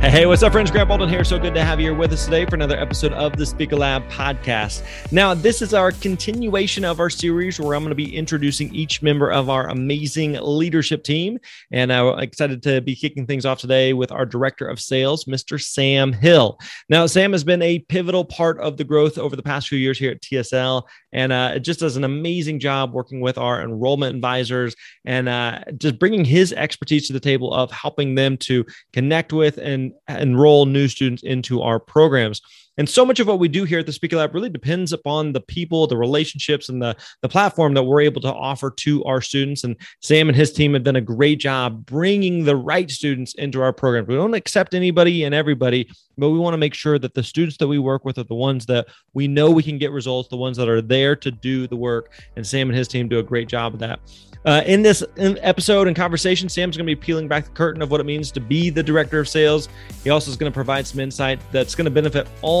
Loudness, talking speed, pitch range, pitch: -19 LUFS, 240 wpm, 130-160 Hz, 145 Hz